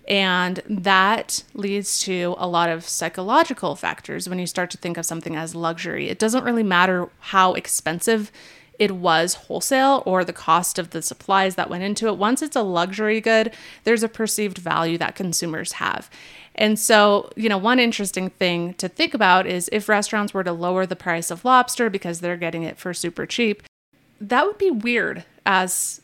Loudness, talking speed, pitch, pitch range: -21 LUFS, 185 wpm, 185 Hz, 175-215 Hz